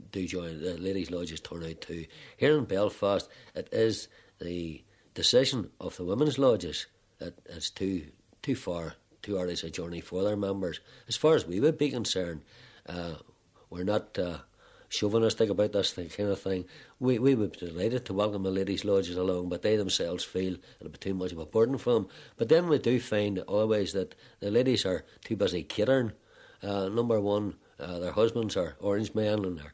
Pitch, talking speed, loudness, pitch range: 100 Hz, 195 wpm, -30 LUFS, 90-115 Hz